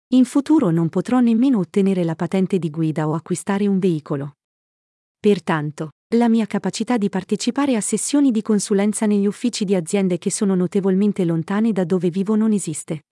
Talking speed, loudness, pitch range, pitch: 170 wpm, -19 LUFS, 175-220 Hz, 200 Hz